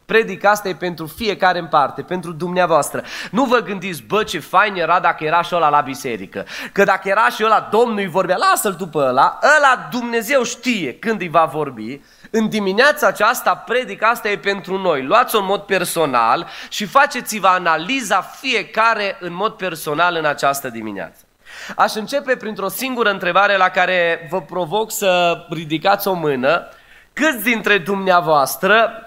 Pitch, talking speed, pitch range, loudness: 195 Hz, 160 wpm, 175-225 Hz, -17 LUFS